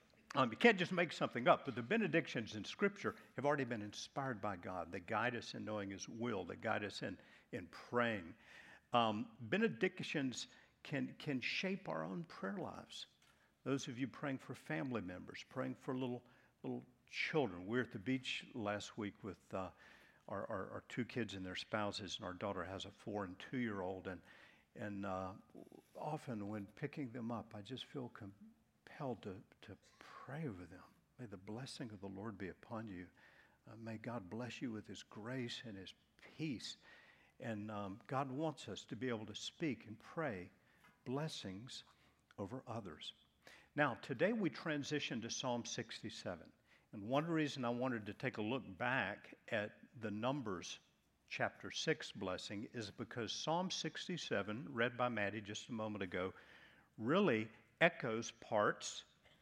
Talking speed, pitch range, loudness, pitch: 170 wpm, 105-135 Hz, -43 LUFS, 115 Hz